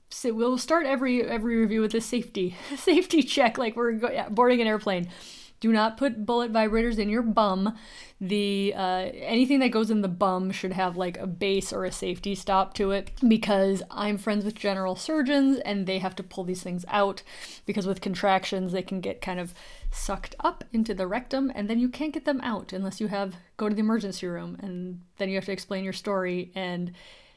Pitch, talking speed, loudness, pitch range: 205 Hz, 210 wpm, -27 LUFS, 190-235 Hz